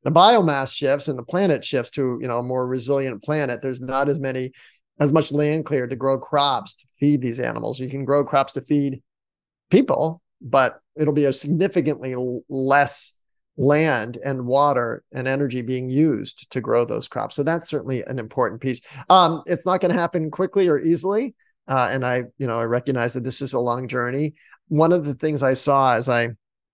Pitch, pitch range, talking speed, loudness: 140 Hz, 130-155 Hz, 200 wpm, -21 LUFS